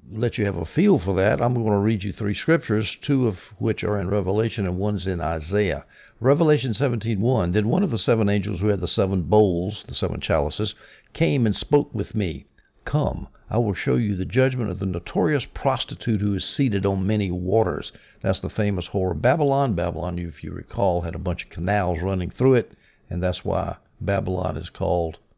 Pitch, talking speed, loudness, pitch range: 105 Hz, 205 wpm, -23 LUFS, 90-110 Hz